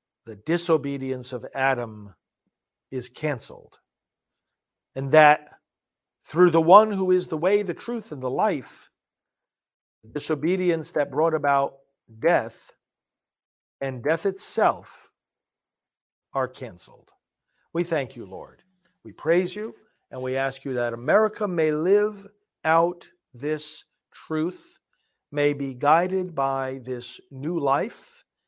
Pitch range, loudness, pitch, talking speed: 135-175 Hz, -24 LUFS, 155 Hz, 120 wpm